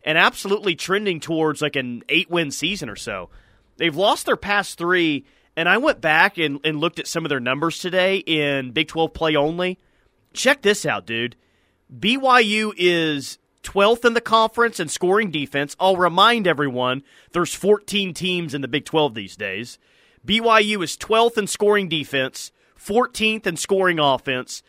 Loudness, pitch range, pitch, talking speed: -20 LUFS, 145-205 Hz, 170 Hz, 170 wpm